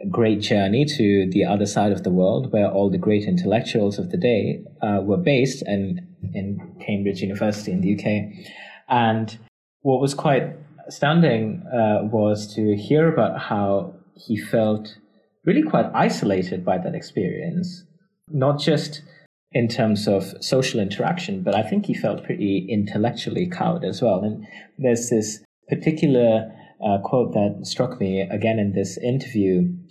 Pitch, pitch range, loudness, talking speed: 110 Hz, 105-155 Hz, -22 LUFS, 150 wpm